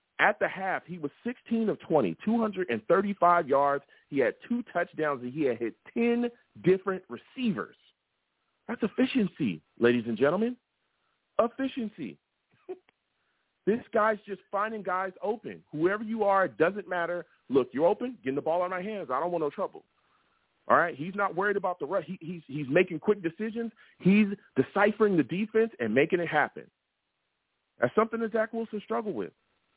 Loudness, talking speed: -29 LUFS, 165 wpm